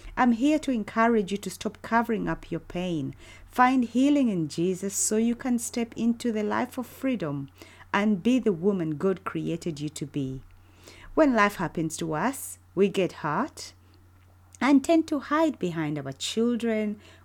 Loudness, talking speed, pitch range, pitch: -26 LUFS, 165 wpm, 150-235 Hz, 195 Hz